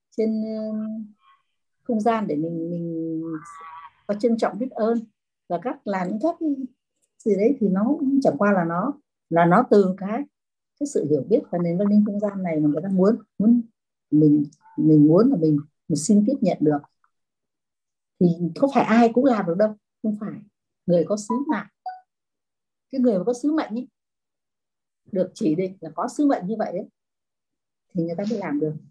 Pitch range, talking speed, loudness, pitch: 170-240 Hz, 190 wpm, -22 LUFS, 210 Hz